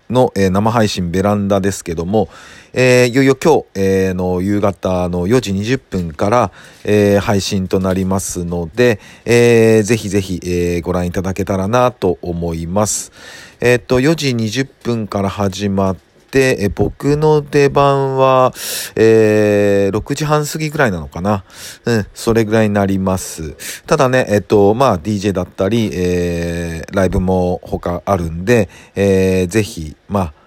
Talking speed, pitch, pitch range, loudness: 280 characters per minute, 100 Hz, 95-120 Hz, -15 LUFS